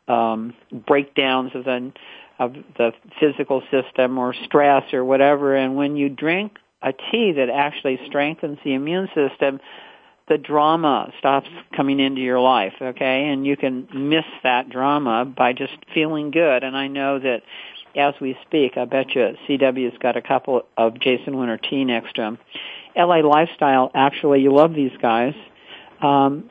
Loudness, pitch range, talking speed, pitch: -20 LUFS, 130-145 Hz, 165 wpm, 135 Hz